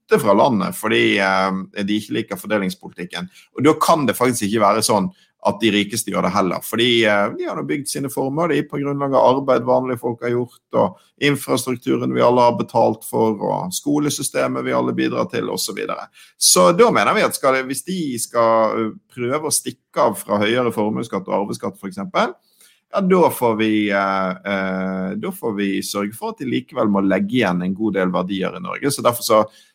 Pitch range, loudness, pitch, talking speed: 95-125 Hz, -19 LUFS, 110 Hz, 220 wpm